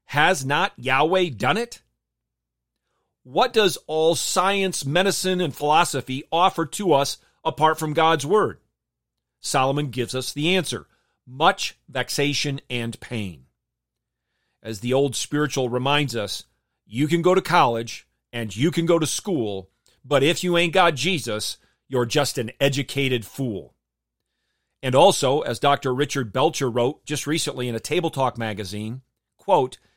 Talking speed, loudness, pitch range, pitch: 140 wpm, -22 LUFS, 115-160 Hz, 135 Hz